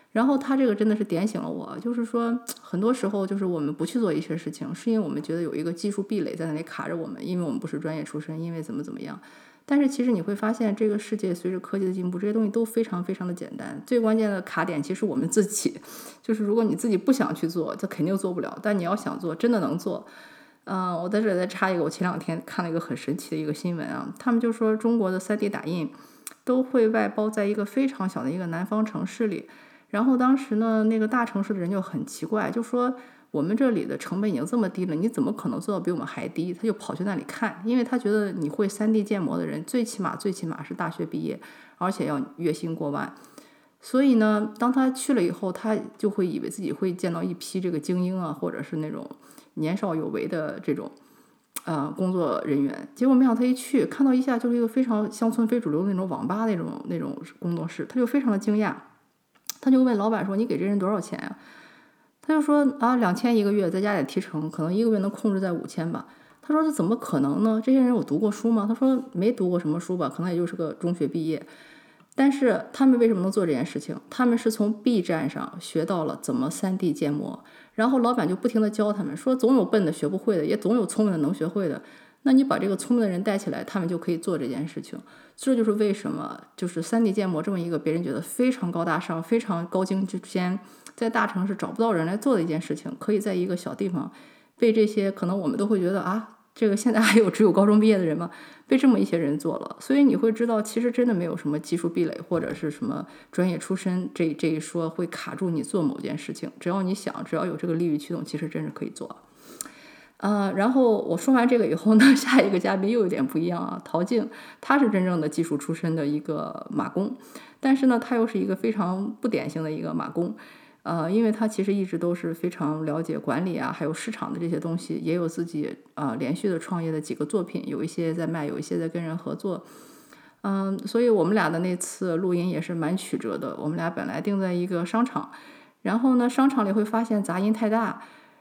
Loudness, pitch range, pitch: -25 LUFS, 175-240 Hz, 210 Hz